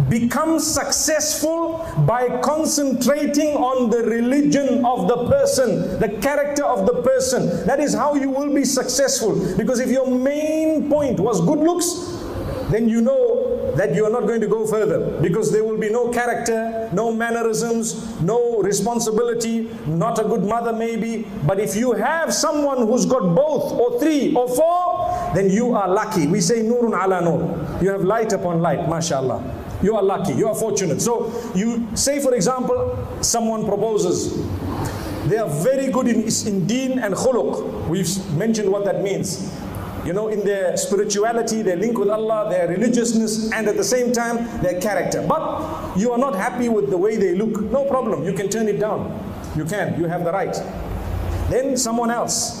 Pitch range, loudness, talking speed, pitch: 195-255 Hz, -20 LUFS, 175 wpm, 225 Hz